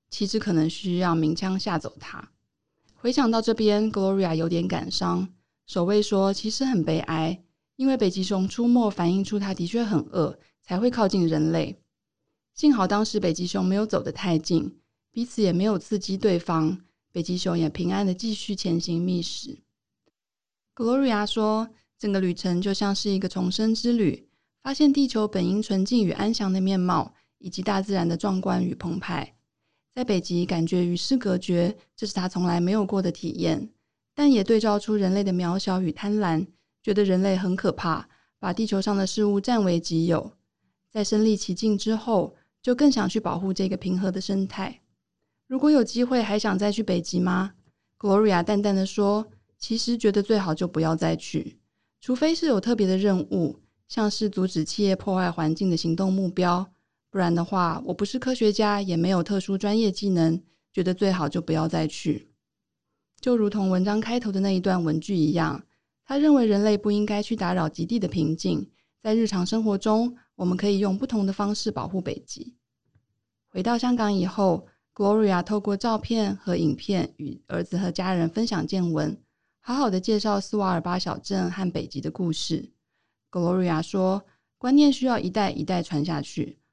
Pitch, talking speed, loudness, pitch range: 190 Hz, 280 characters per minute, -25 LUFS, 175-215 Hz